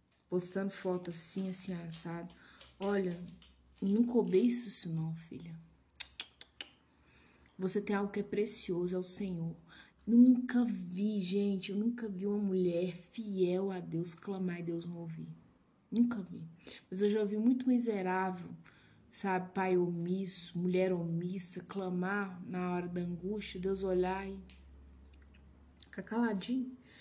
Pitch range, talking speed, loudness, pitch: 170-200 Hz, 135 wpm, -35 LUFS, 185 Hz